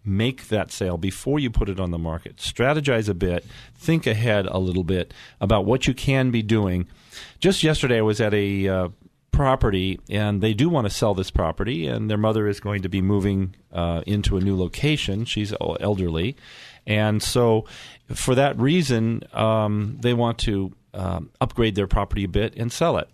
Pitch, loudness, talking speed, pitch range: 105 Hz, -23 LUFS, 190 wpm, 95-120 Hz